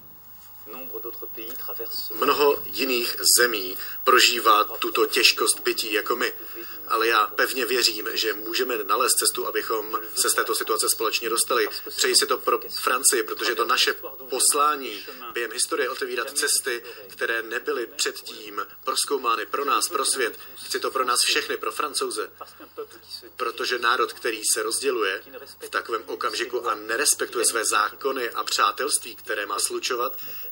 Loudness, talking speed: -23 LUFS, 135 wpm